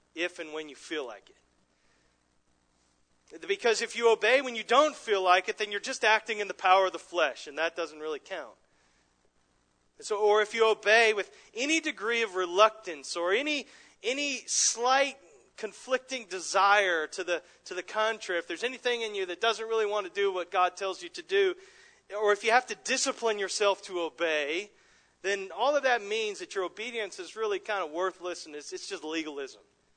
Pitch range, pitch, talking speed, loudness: 170-245 Hz, 205 Hz, 195 wpm, -28 LUFS